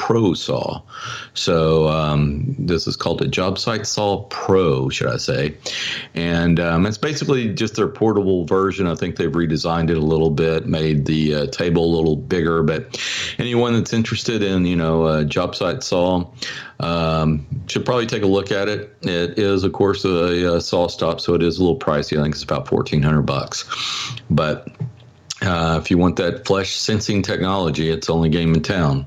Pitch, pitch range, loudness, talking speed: 85 Hz, 80-100 Hz, -19 LUFS, 185 wpm